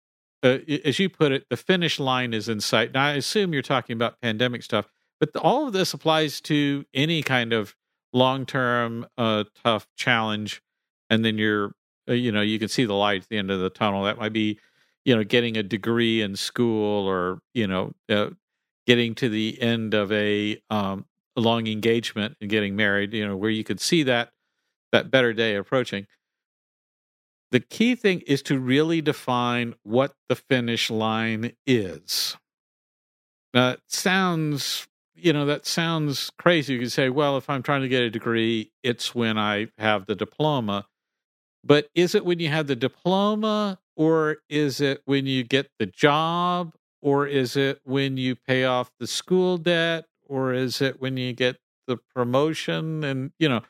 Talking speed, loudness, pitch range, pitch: 180 wpm, -24 LUFS, 110-145 Hz, 125 Hz